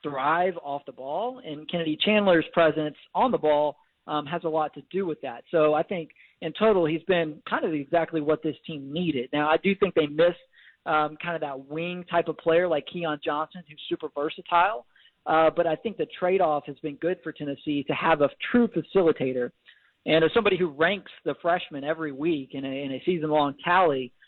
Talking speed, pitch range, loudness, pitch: 210 wpm, 150-175 Hz, -26 LUFS, 160 Hz